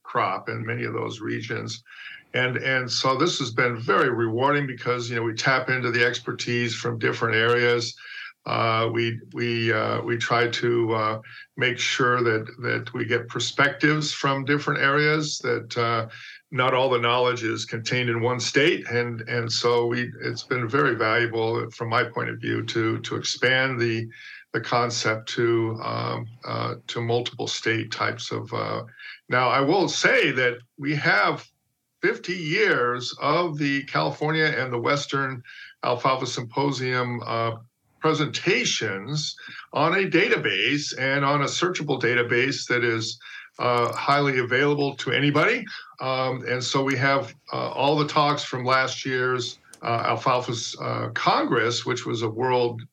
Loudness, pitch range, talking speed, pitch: -24 LUFS, 120-135 Hz, 155 wpm, 125 Hz